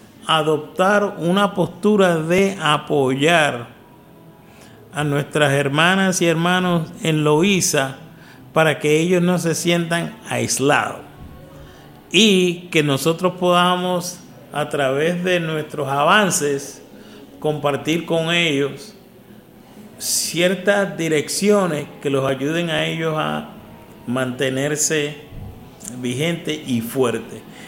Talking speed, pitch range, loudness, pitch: 95 wpm, 145-175 Hz, -18 LUFS, 160 Hz